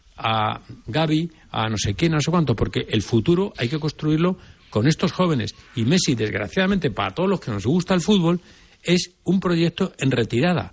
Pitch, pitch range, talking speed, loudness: 155 Hz, 115-180 Hz, 190 wpm, -22 LUFS